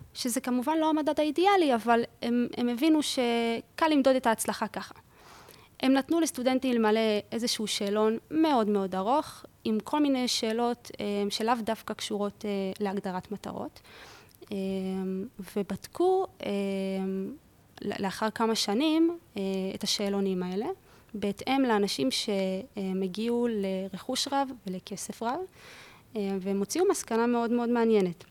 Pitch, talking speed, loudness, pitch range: 225 Hz, 110 wpm, -29 LUFS, 200-260 Hz